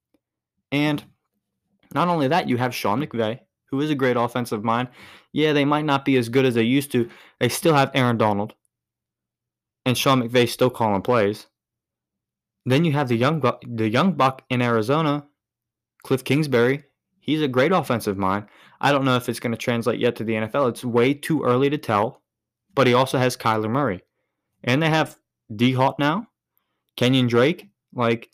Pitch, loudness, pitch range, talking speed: 125 Hz, -21 LUFS, 115-140 Hz, 185 wpm